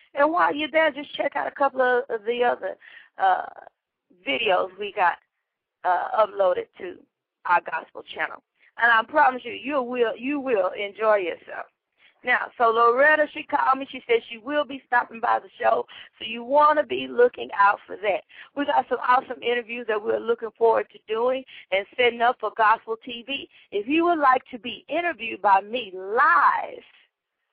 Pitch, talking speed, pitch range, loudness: 255 Hz, 180 wpm, 230-300 Hz, -23 LUFS